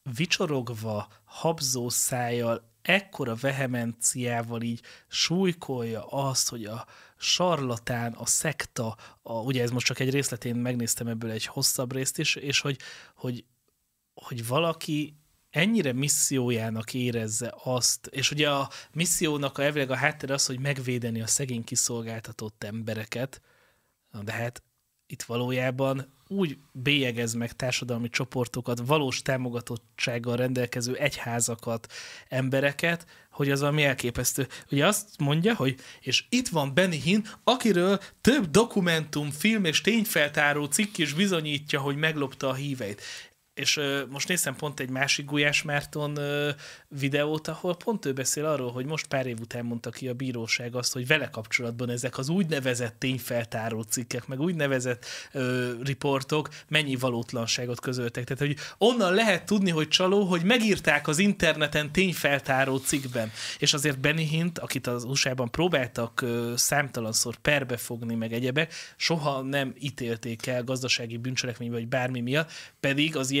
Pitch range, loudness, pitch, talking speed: 120-150 Hz, -27 LUFS, 135 Hz, 140 wpm